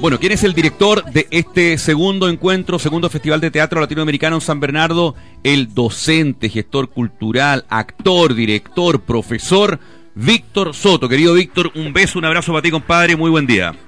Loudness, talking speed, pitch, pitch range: -14 LUFS, 165 wpm, 160 Hz, 140-175 Hz